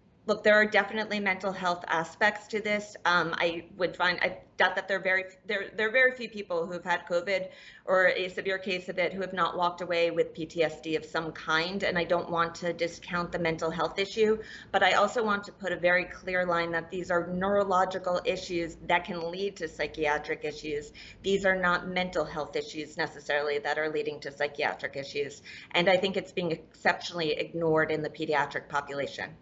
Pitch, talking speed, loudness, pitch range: 175 Hz, 200 wpm, -29 LUFS, 160-190 Hz